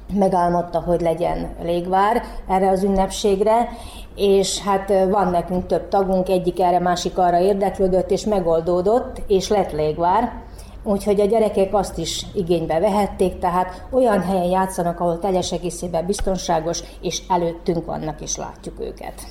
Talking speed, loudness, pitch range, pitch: 135 wpm, -20 LUFS, 175-200 Hz, 190 Hz